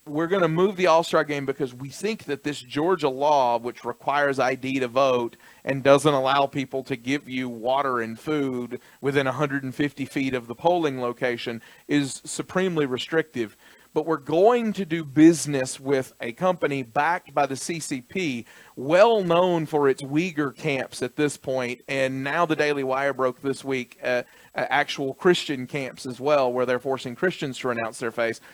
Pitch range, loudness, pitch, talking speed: 130-155 Hz, -24 LUFS, 140 Hz, 175 wpm